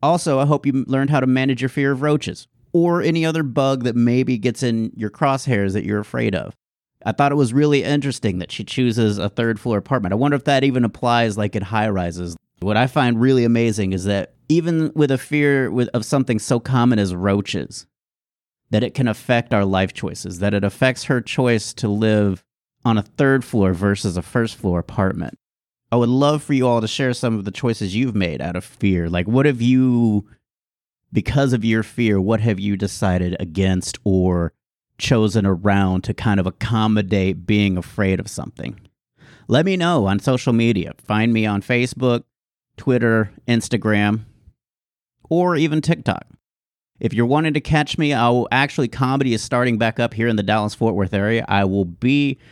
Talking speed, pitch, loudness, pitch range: 195 wpm, 115 Hz, -19 LUFS, 100-130 Hz